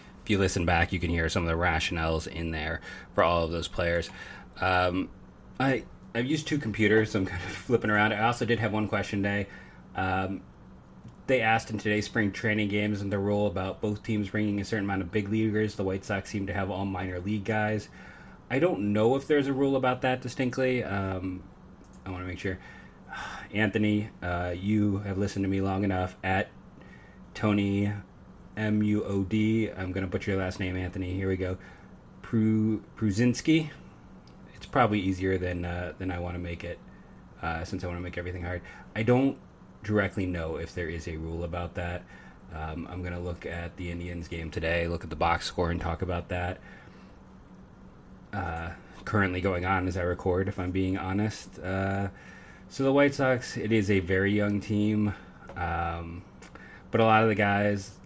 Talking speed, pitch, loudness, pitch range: 195 wpm, 95 Hz, -29 LUFS, 90-105 Hz